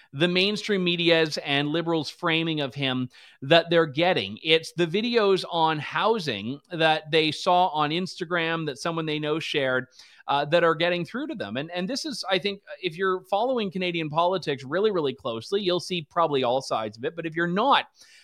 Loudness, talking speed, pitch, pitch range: -25 LUFS, 190 wpm, 170 Hz, 155-185 Hz